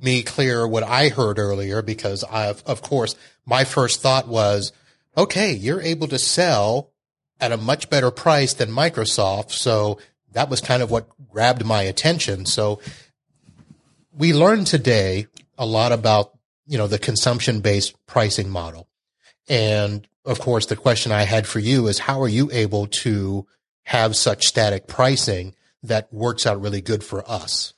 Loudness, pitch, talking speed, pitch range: -20 LUFS, 115 Hz, 160 wpm, 105-130 Hz